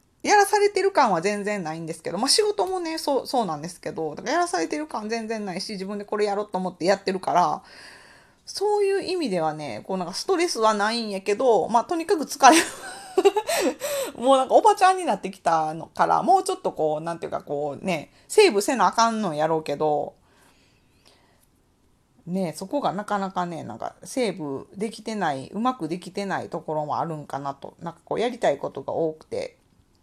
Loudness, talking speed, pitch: -24 LUFS, 405 characters per minute, 210 Hz